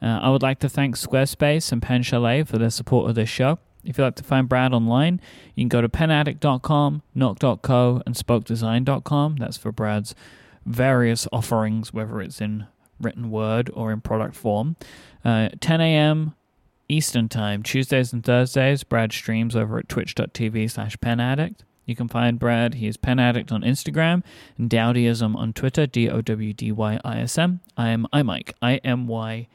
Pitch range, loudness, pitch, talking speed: 115-135 Hz, -22 LUFS, 120 Hz, 160 wpm